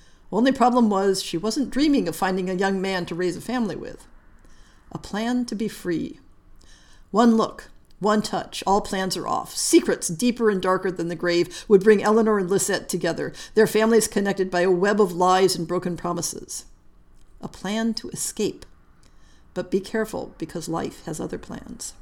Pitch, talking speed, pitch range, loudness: 195 Hz, 175 wpm, 180-220 Hz, -23 LUFS